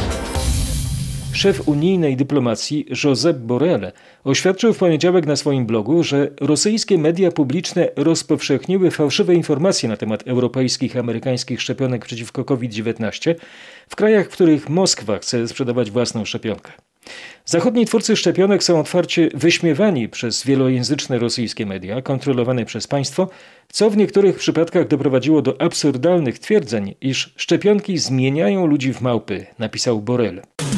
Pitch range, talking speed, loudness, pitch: 125-175 Hz, 125 wpm, -18 LUFS, 140 Hz